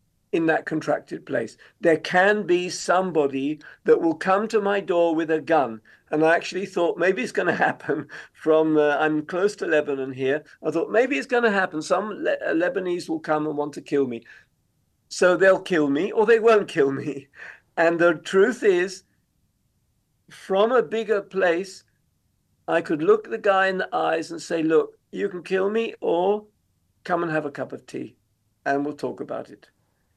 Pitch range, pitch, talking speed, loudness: 150-200 Hz, 175 Hz, 190 wpm, -23 LUFS